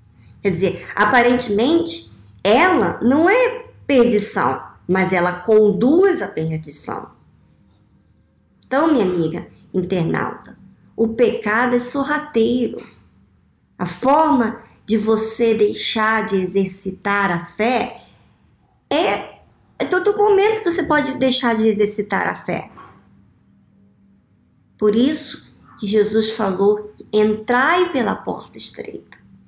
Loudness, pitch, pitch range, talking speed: -18 LUFS, 220 Hz, 190-255 Hz, 105 wpm